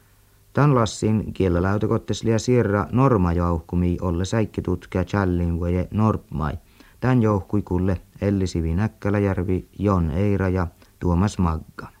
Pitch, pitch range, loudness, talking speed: 95 Hz, 90-105 Hz, -22 LUFS, 90 wpm